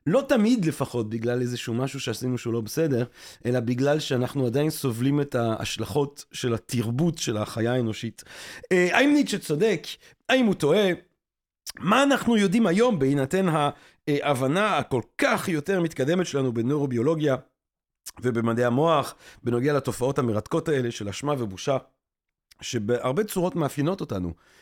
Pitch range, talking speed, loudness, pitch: 120-170 Hz, 135 wpm, -25 LUFS, 140 Hz